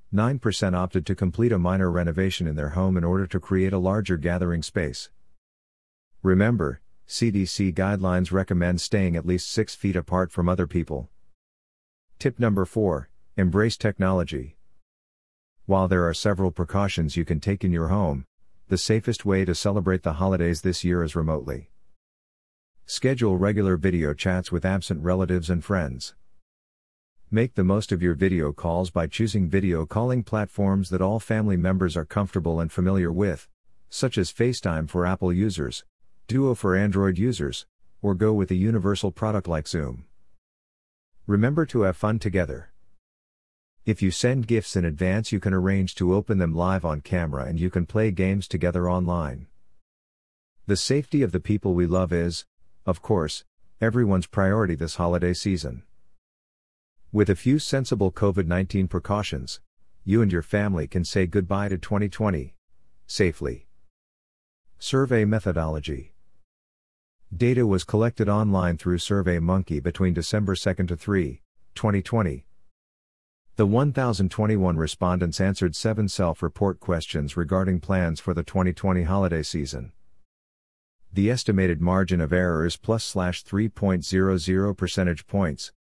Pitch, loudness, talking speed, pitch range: 95 Hz, -24 LUFS, 140 wpm, 85-100 Hz